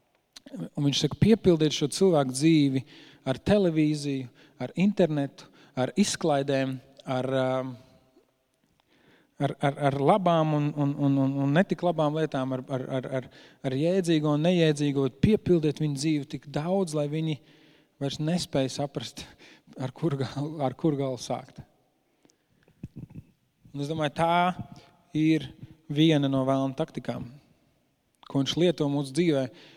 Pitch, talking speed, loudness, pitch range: 145 Hz, 125 wpm, -27 LUFS, 135-160 Hz